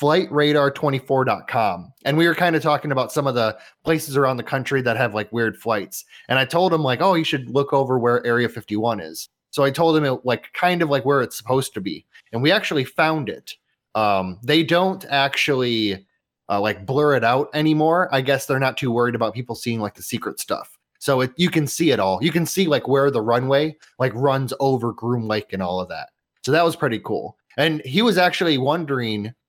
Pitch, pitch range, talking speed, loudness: 135 Hz, 120-155 Hz, 220 wpm, -20 LUFS